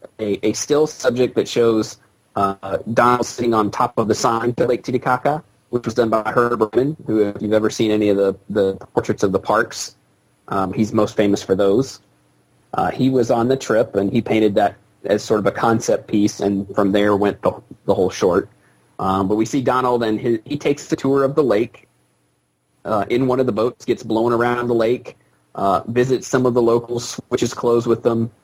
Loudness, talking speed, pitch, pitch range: -19 LUFS, 210 wpm, 115 Hz, 100-125 Hz